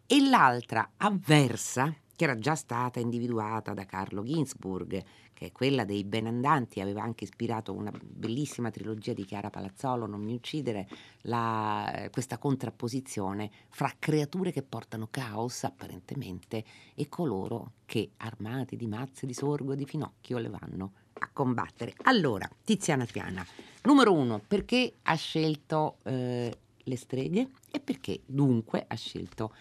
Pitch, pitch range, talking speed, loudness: 120 Hz, 105-140 Hz, 140 wpm, -31 LUFS